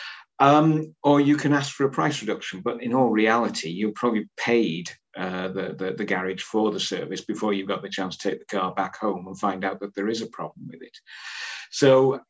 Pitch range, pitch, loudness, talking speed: 95-130 Hz, 105 Hz, -24 LUFS, 230 wpm